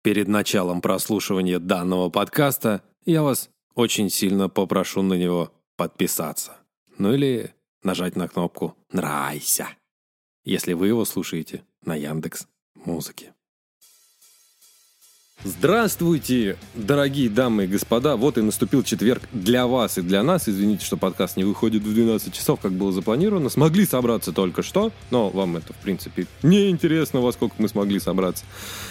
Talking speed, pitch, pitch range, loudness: 135 wpm, 105 Hz, 95-125 Hz, -22 LUFS